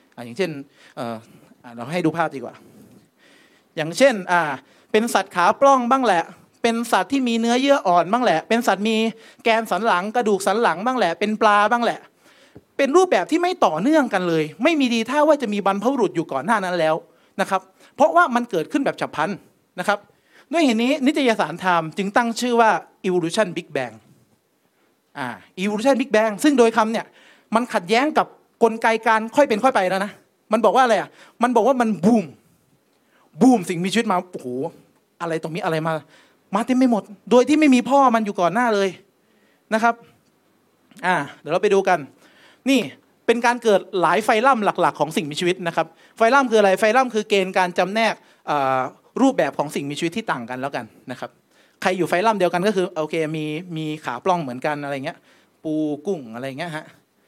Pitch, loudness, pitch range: 205 Hz, -20 LUFS, 170-240 Hz